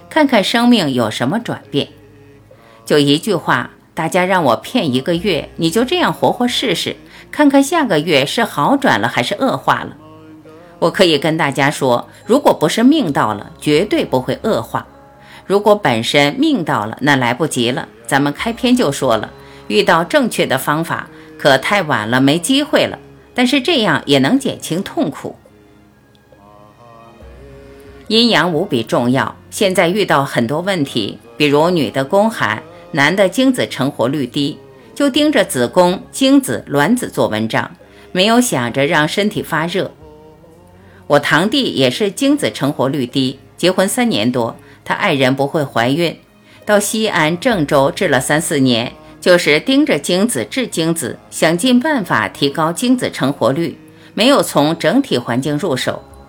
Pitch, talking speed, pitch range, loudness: 150 Hz, 230 characters per minute, 130-205 Hz, -15 LUFS